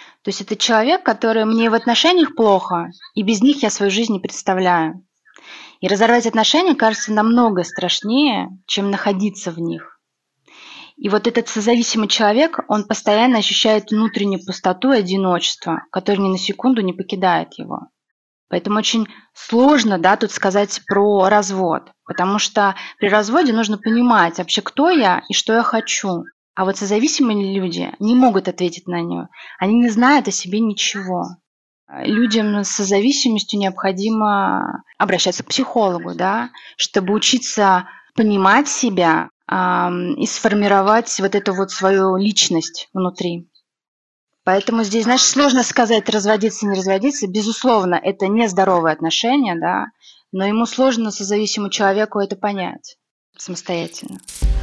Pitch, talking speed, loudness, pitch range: 210 Hz, 135 wpm, -17 LUFS, 190-230 Hz